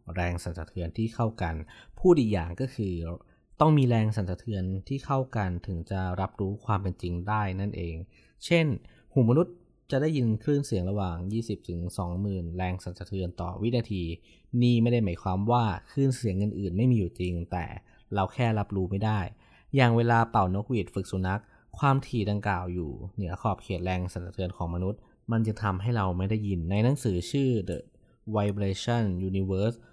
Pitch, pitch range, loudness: 100 Hz, 90-115 Hz, -29 LUFS